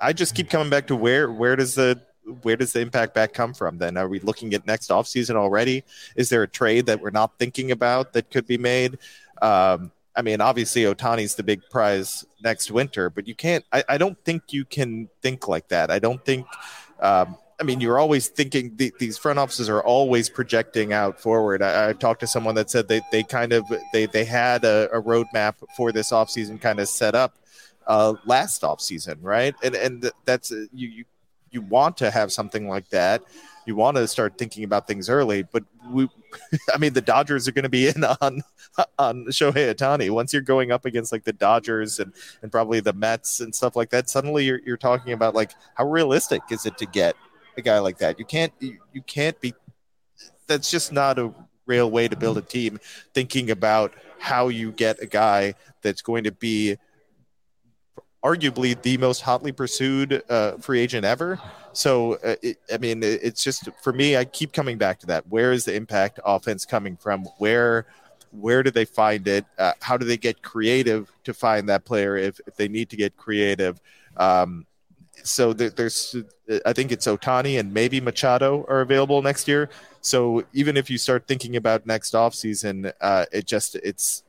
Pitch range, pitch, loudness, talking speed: 110-130 Hz, 120 Hz, -22 LUFS, 205 wpm